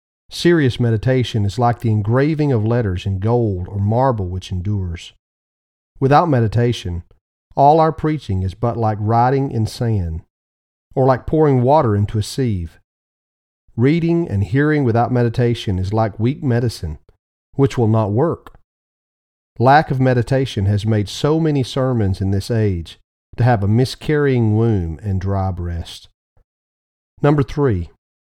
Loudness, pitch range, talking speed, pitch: -17 LUFS, 95-130 Hz, 140 wpm, 110 Hz